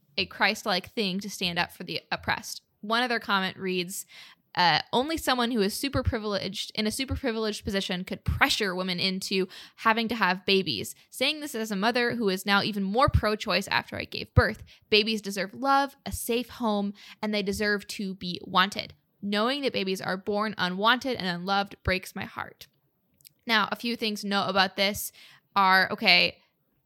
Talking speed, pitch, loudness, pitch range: 180 wpm, 205 Hz, -27 LUFS, 190-230 Hz